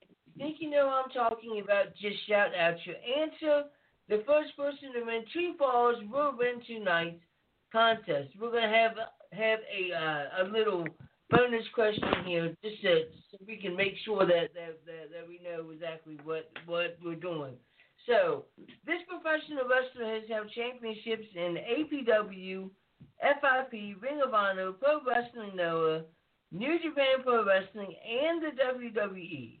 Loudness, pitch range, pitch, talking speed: -31 LUFS, 175-255 Hz, 220 Hz, 150 wpm